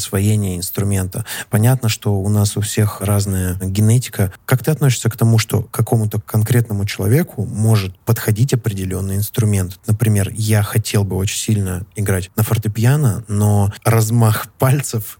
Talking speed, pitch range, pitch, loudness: 140 wpm, 100-115 Hz, 110 Hz, -17 LUFS